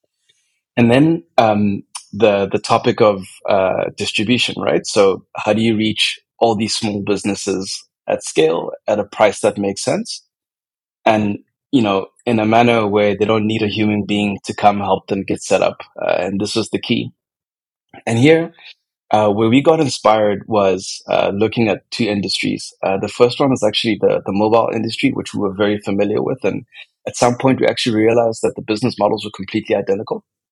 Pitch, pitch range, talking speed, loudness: 105 Hz, 100-115 Hz, 190 wpm, -16 LUFS